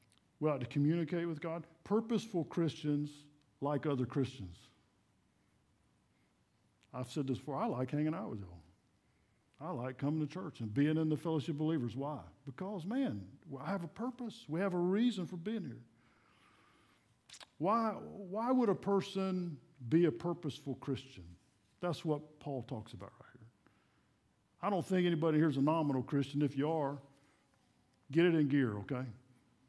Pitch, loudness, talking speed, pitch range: 145 Hz, -37 LUFS, 160 wpm, 125-170 Hz